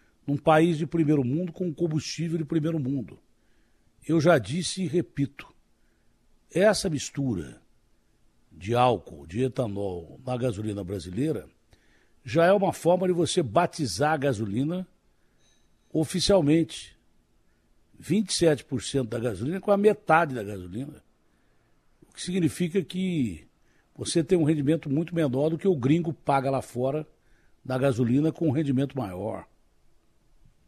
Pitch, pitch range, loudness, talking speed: 145 Hz, 125-170 Hz, -26 LUFS, 125 wpm